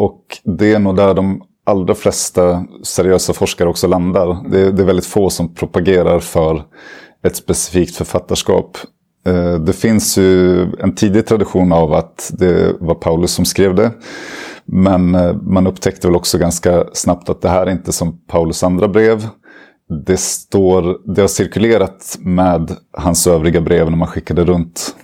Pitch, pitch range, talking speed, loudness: 90 Hz, 85-95 Hz, 160 wpm, -14 LUFS